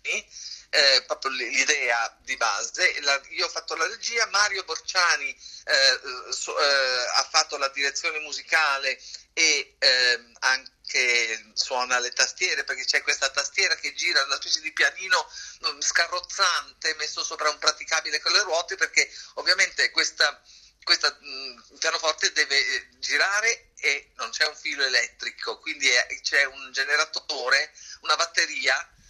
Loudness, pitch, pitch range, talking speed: -23 LUFS, 155 Hz, 135-165 Hz, 135 wpm